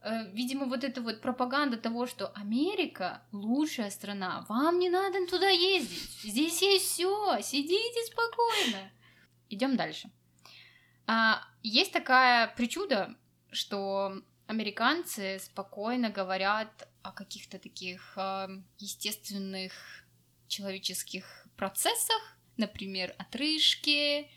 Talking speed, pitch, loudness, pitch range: 90 wpm, 225 Hz, -30 LUFS, 195-300 Hz